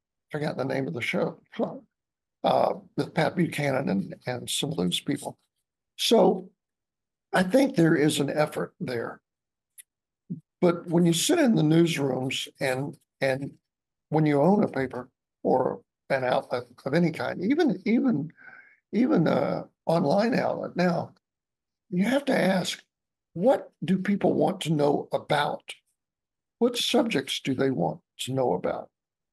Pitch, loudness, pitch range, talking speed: 165 Hz, -26 LUFS, 135-195 Hz, 145 wpm